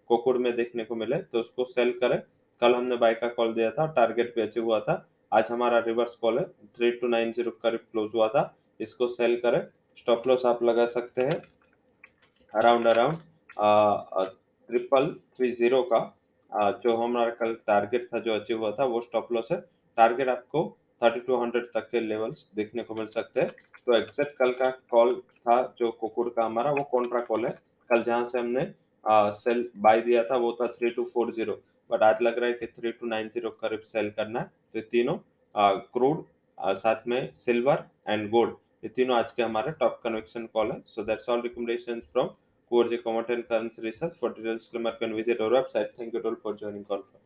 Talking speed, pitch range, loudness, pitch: 185 wpm, 115-120 Hz, -27 LUFS, 120 Hz